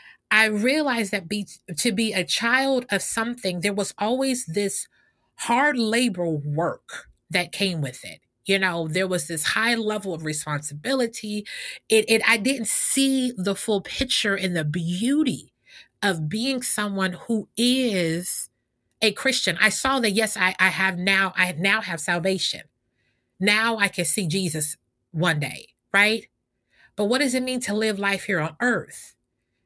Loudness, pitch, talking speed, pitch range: -23 LUFS, 200 Hz, 160 wpm, 175-225 Hz